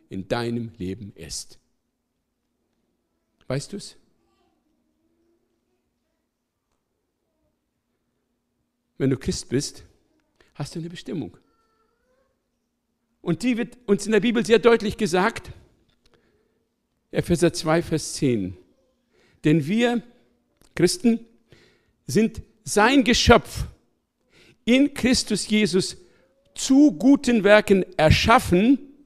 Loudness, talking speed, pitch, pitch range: -21 LUFS, 85 wpm, 210 Hz, 155-235 Hz